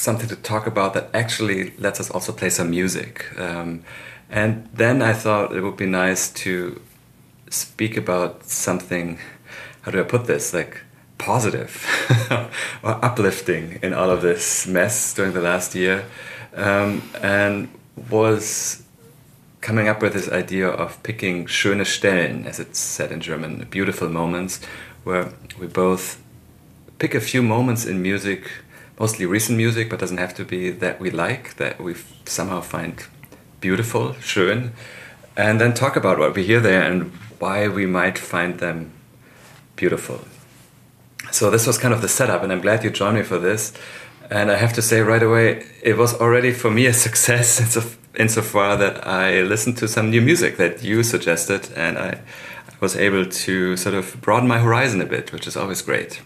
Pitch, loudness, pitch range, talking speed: 100 Hz, -20 LUFS, 90-115 Hz, 170 wpm